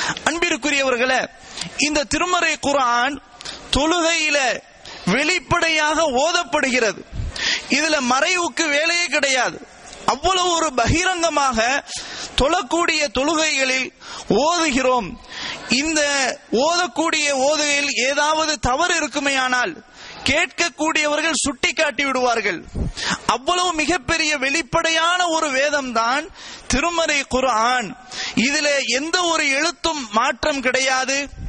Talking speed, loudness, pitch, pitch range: 80 wpm, -18 LUFS, 300 Hz, 260-330 Hz